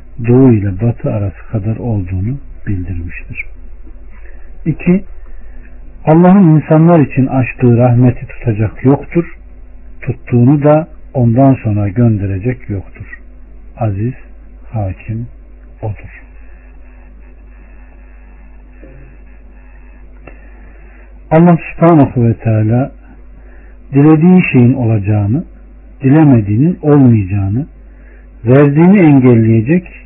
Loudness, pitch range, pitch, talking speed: -11 LUFS, 105-145 Hz, 120 Hz, 70 wpm